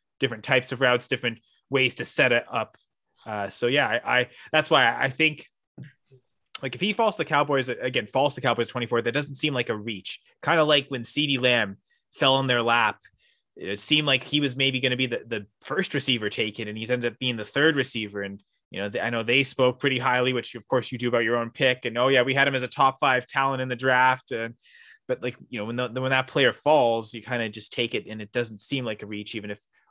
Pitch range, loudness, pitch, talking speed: 115-135 Hz, -24 LUFS, 125 Hz, 260 wpm